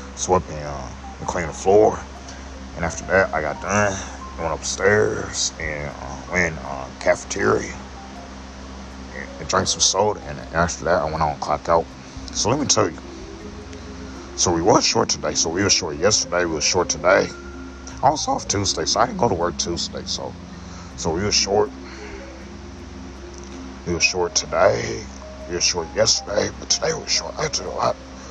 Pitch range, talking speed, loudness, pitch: 65-85 Hz, 190 wpm, -20 LUFS, 70 Hz